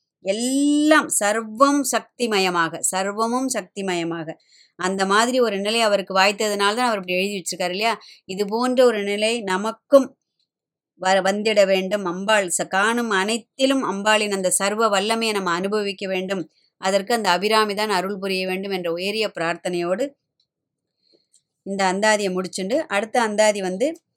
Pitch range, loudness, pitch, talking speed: 190-225 Hz, -21 LUFS, 200 Hz, 125 wpm